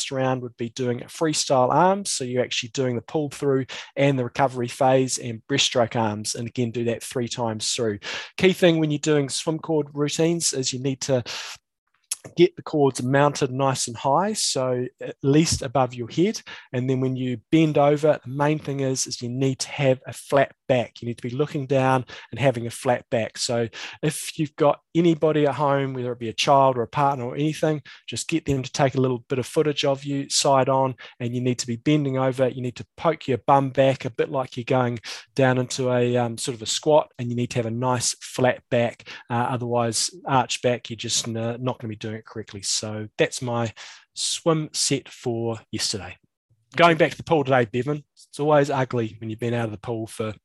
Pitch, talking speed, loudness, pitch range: 130 Hz, 220 wpm, -23 LUFS, 120-145 Hz